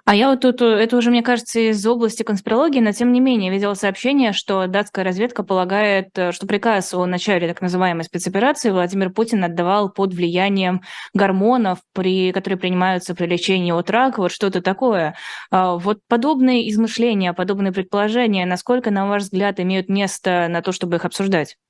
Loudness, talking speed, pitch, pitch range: -18 LUFS, 165 wpm, 195 Hz, 185-225 Hz